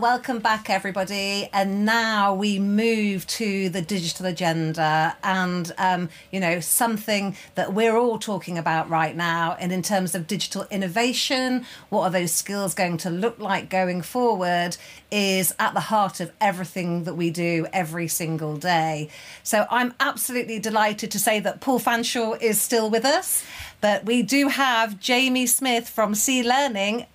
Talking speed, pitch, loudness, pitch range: 160 wpm, 200 Hz, -23 LUFS, 180-230 Hz